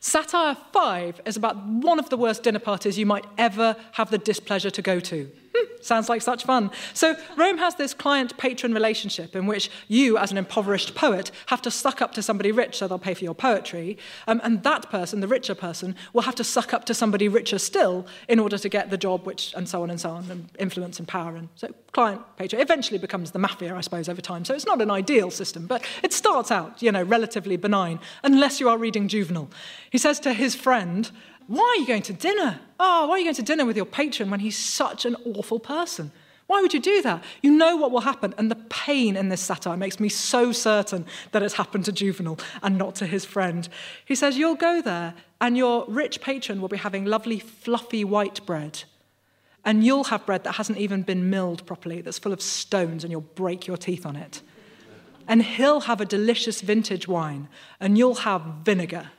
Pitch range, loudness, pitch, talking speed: 190-245 Hz, -24 LUFS, 215 Hz, 220 wpm